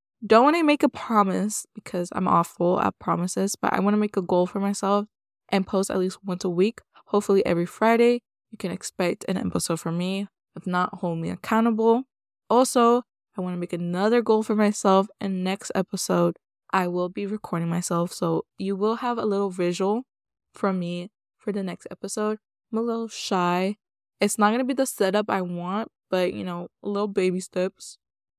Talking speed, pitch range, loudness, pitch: 190 wpm, 180-215 Hz, -24 LUFS, 195 Hz